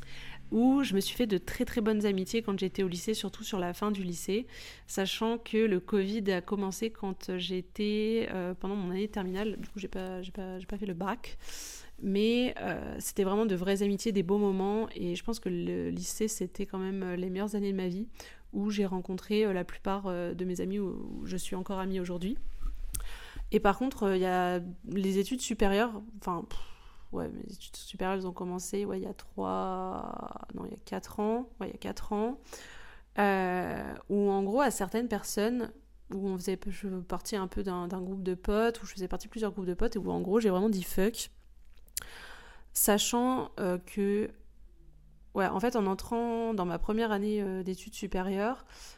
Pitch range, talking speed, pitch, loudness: 185-215 Hz, 210 wpm, 200 Hz, -32 LUFS